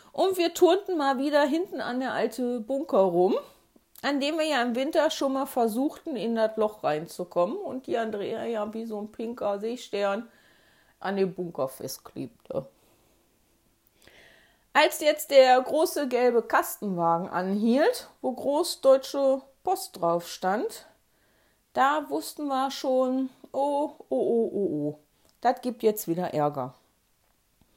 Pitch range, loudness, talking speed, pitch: 195-285 Hz, -27 LUFS, 135 wpm, 245 Hz